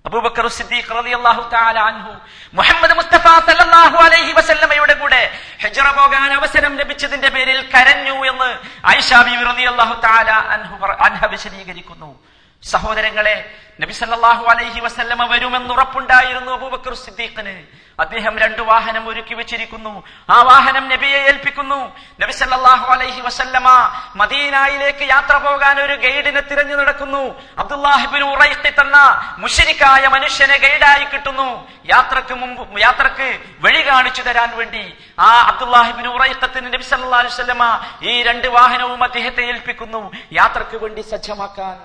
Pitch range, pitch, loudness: 230-275 Hz, 255 Hz, -12 LUFS